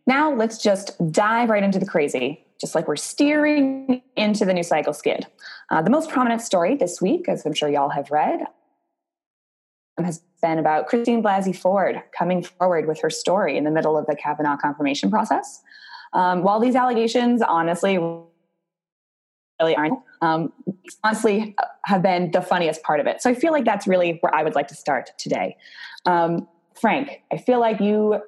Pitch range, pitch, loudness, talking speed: 160-225 Hz, 185 Hz, -21 LUFS, 180 wpm